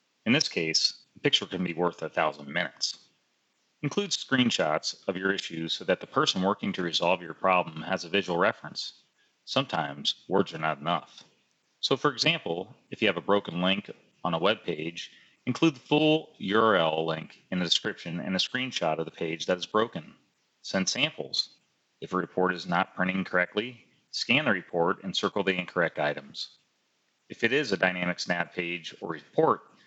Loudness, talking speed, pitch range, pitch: -28 LUFS, 180 wpm, 85-110 Hz, 95 Hz